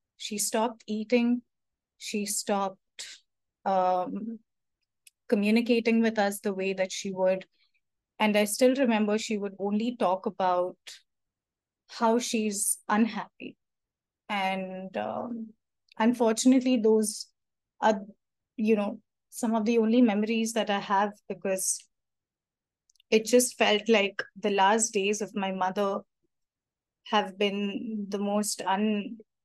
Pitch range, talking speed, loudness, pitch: 200-225 Hz, 115 wpm, -27 LUFS, 210 Hz